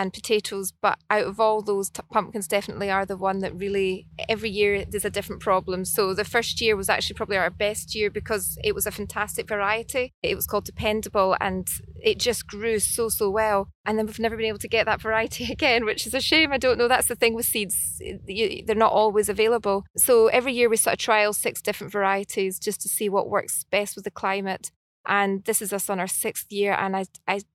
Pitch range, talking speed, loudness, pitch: 200-225 Hz, 230 wpm, -24 LUFS, 210 Hz